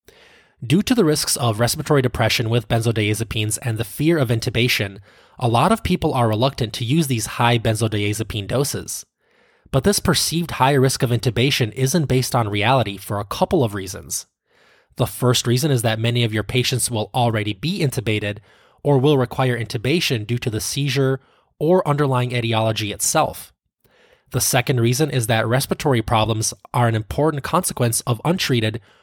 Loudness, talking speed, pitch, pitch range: -20 LUFS, 165 wpm, 125 Hz, 110-140 Hz